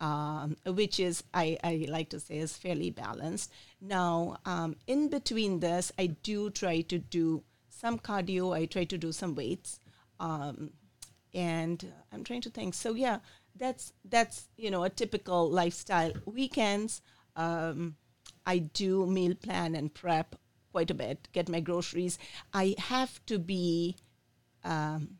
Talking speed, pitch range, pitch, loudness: 150 wpm, 155-195 Hz, 175 Hz, -33 LUFS